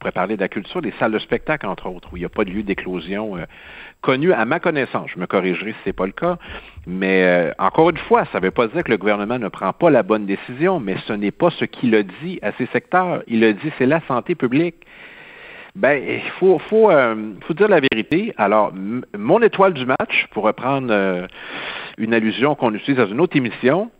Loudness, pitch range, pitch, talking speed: -19 LUFS, 105-175 Hz, 125 Hz, 245 wpm